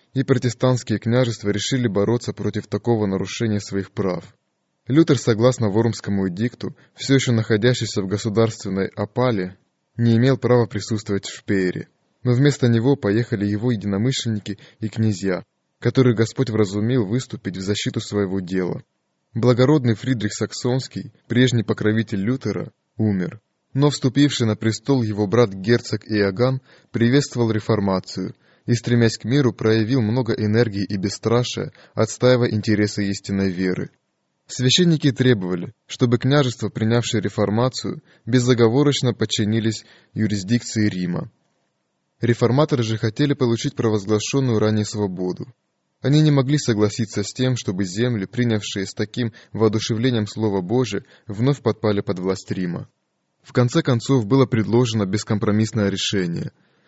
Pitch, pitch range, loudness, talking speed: 115 Hz, 105-125 Hz, -21 LUFS, 120 wpm